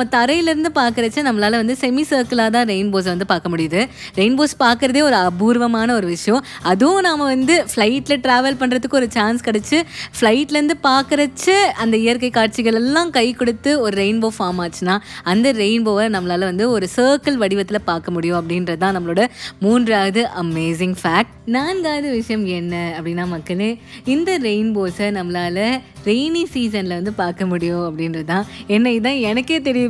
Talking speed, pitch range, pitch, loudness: 145 wpm, 190-260 Hz, 225 Hz, -17 LUFS